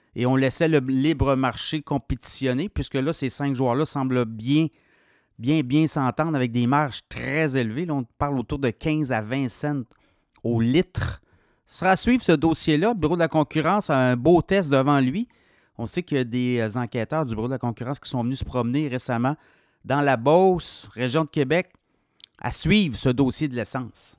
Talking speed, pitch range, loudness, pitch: 200 wpm, 125-155 Hz, -23 LUFS, 135 Hz